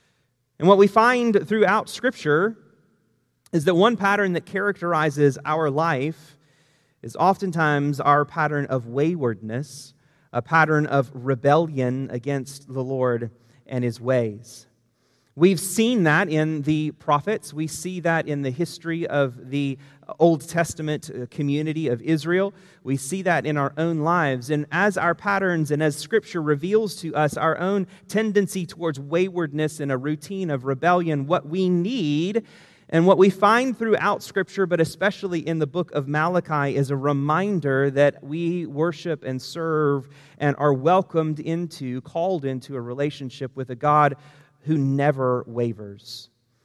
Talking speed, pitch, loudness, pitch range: 145 wpm, 155 Hz, -22 LUFS, 140-175 Hz